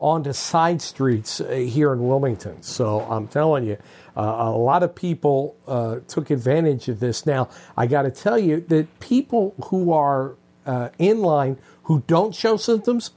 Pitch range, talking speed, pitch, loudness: 125-165 Hz, 170 wpm, 140 Hz, -21 LUFS